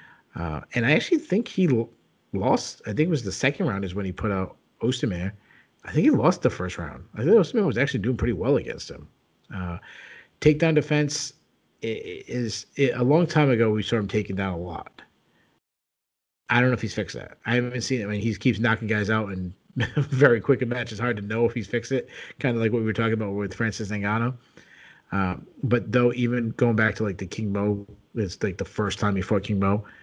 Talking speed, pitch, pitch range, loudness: 235 wpm, 115 Hz, 100-125 Hz, -25 LUFS